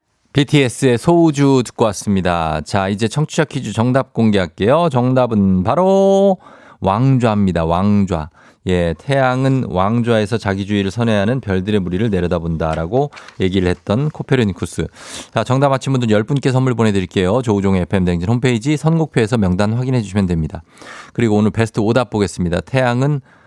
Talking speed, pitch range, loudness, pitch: 365 characters per minute, 95-130 Hz, -16 LUFS, 115 Hz